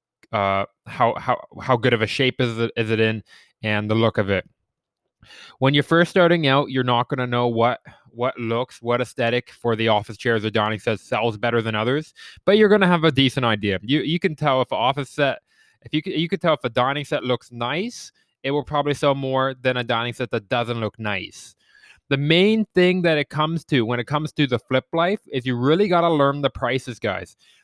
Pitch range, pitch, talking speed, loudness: 115-150 Hz, 130 Hz, 230 wpm, -21 LUFS